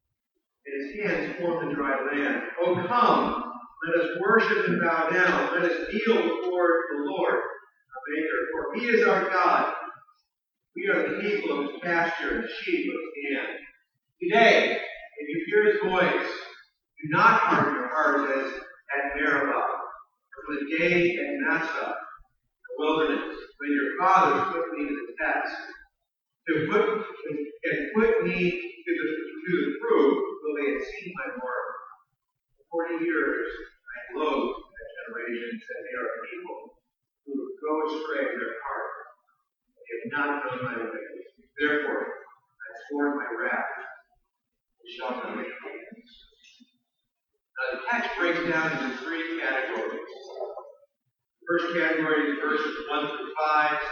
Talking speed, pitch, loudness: 150 wpm, 180 Hz, -26 LUFS